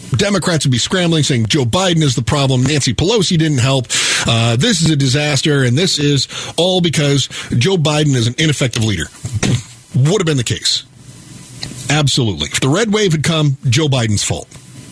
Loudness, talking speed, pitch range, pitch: -14 LUFS, 180 wpm, 125-155 Hz, 140 Hz